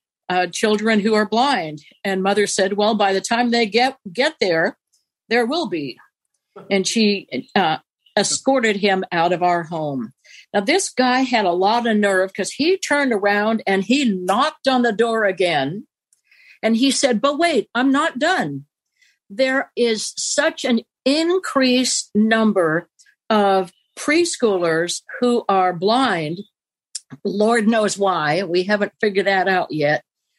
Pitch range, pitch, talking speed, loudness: 195-260 Hz, 220 Hz, 150 wpm, -19 LUFS